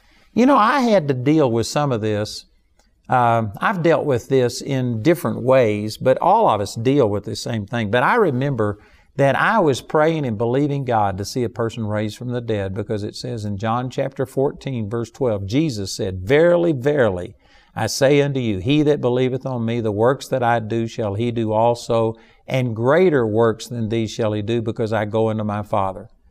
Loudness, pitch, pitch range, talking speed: -19 LUFS, 115 Hz, 110-135 Hz, 205 wpm